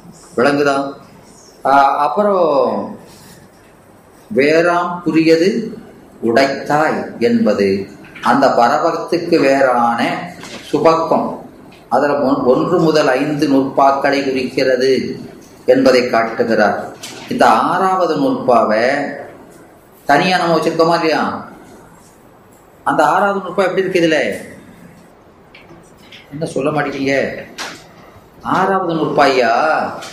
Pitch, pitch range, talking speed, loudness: 150 Hz, 135-175 Hz, 65 wpm, -14 LUFS